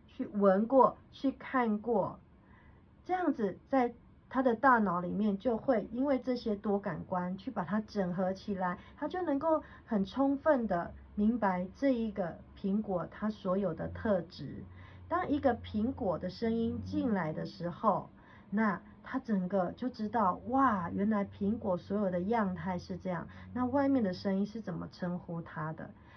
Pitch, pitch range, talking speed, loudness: 210 Hz, 185-250 Hz, 225 characters per minute, -33 LUFS